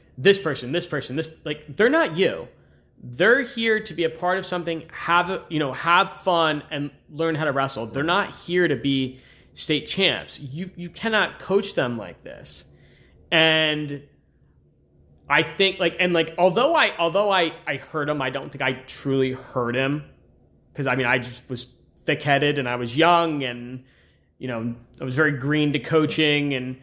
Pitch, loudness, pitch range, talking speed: 150 Hz, -22 LUFS, 130-170 Hz, 185 wpm